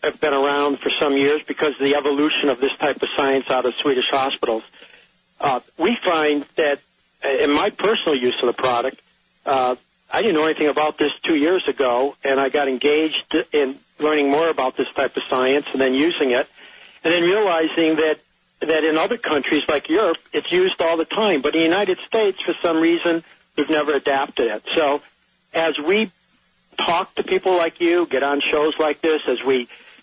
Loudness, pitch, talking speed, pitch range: -19 LUFS, 155 Hz, 195 wpm, 140-170 Hz